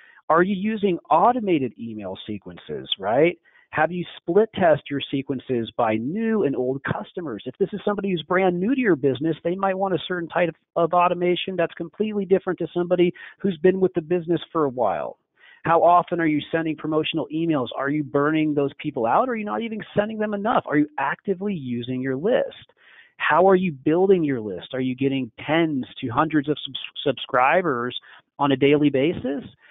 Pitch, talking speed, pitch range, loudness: 165 Hz, 195 wpm, 140-185 Hz, -23 LUFS